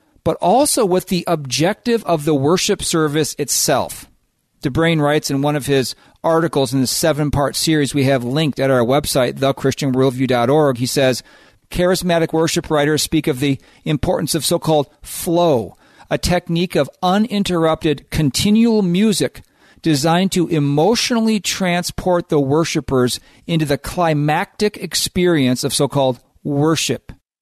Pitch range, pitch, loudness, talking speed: 140-175 Hz, 155 Hz, -17 LUFS, 135 wpm